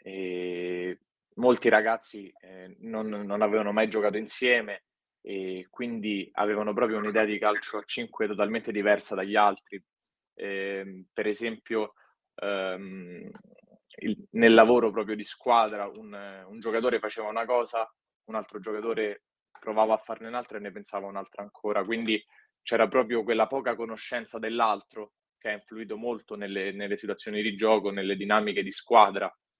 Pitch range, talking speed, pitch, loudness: 100-115 Hz, 145 wpm, 105 Hz, -28 LUFS